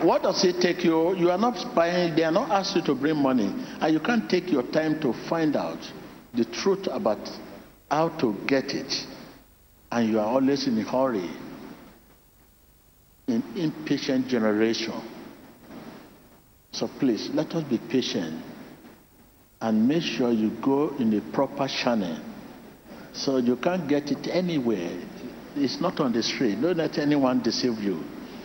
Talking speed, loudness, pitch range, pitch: 155 wpm, -25 LUFS, 115-175 Hz, 145 Hz